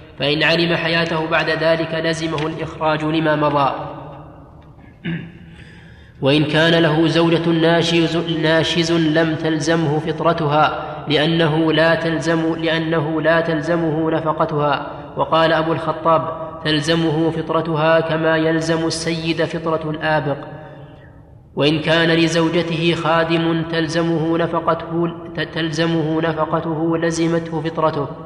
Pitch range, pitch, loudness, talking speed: 155-165 Hz, 160 Hz, -18 LUFS, 95 wpm